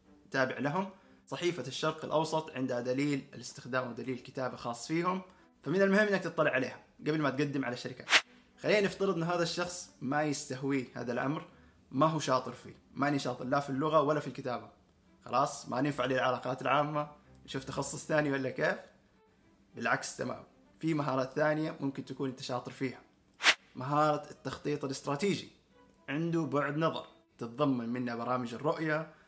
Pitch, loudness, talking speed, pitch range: 140 Hz, -33 LUFS, 150 wpm, 130-155 Hz